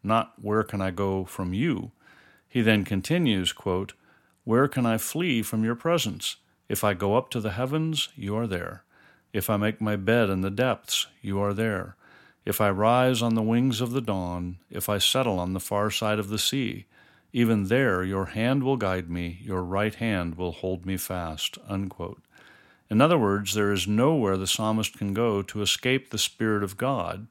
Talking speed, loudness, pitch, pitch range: 195 wpm, -26 LUFS, 105 Hz, 95-115 Hz